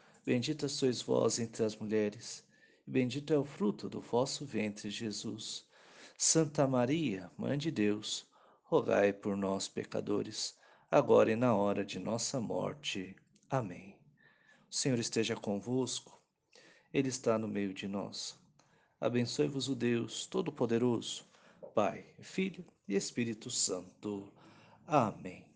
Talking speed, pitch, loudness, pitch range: 120 wpm, 115 Hz, -35 LUFS, 105-135 Hz